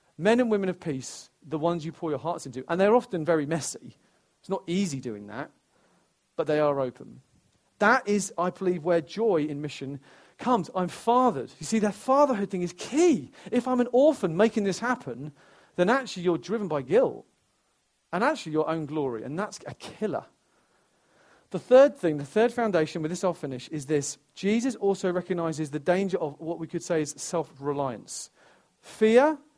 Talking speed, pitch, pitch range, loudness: 185 wpm, 175 Hz, 150-215 Hz, -26 LUFS